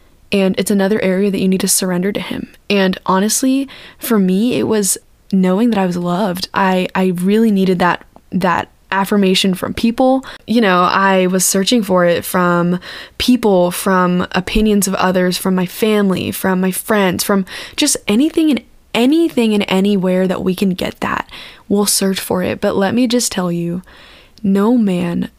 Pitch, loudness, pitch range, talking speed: 195 Hz, -15 LUFS, 185-220 Hz, 175 wpm